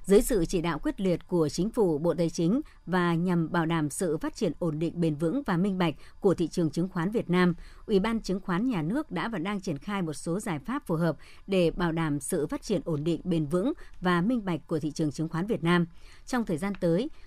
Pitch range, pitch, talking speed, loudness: 165-200 Hz, 175 Hz, 255 wpm, -29 LUFS